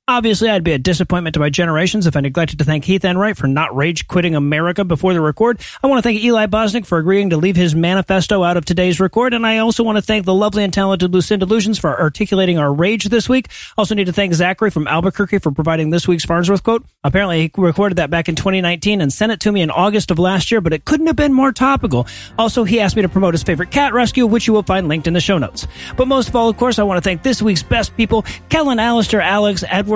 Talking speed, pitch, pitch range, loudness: 260 wpm, 190 Hz, 170-220 Hz, -15 LUFS